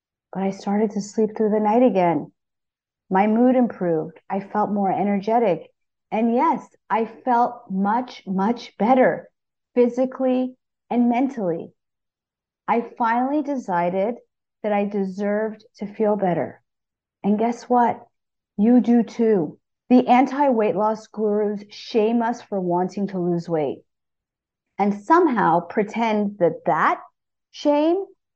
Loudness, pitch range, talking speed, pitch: -21 LUFS, 195-245 Hz, 125 wpm, 215 Hz